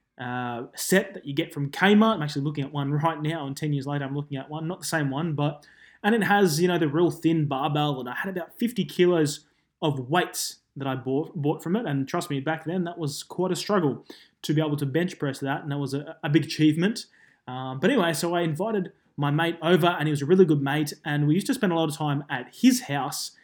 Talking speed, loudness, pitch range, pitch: 260 wpm, -25 LUFS, 145-175 Hz, 155 Hz